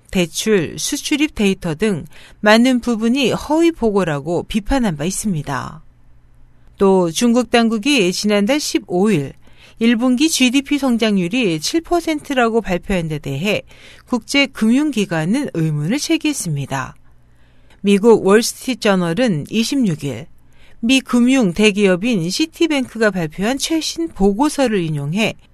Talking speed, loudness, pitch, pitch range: 245 characters per minute, -17 LUFS, 215 Hz, 175-260 Hz